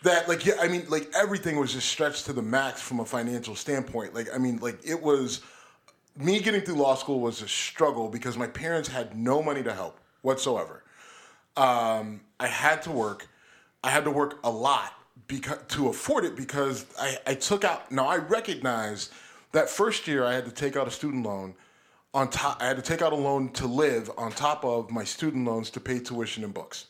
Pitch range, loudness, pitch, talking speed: 120-150 Hz, -28 LUFS, 130 Hz, 215 wpm